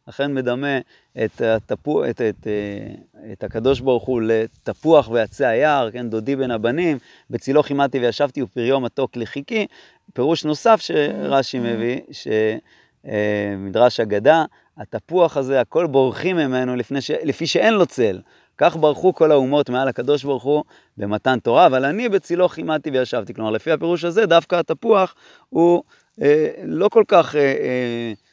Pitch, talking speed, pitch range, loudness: 135 Hz, 140 wpm, 120-160 Hz, -19 LUFS